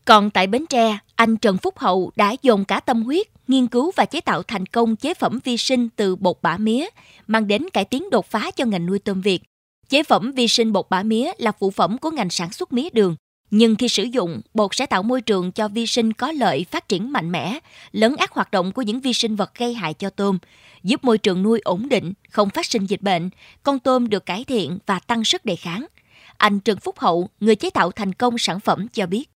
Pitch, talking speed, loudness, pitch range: 220 Hz, 245 wpm, -20 LUFS, 195-245 Hz